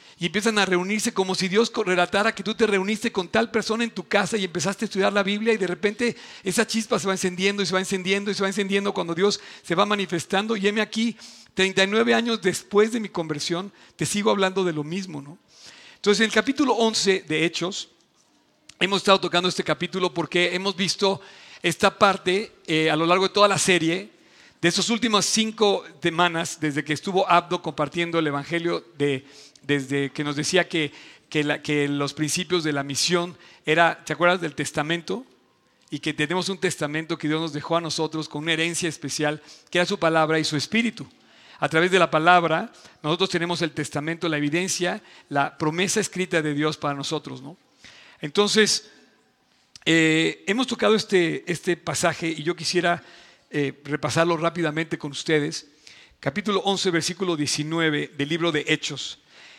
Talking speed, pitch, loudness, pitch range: 180 wpm, 175 Hz, -23 LUFS, 155-200 Hz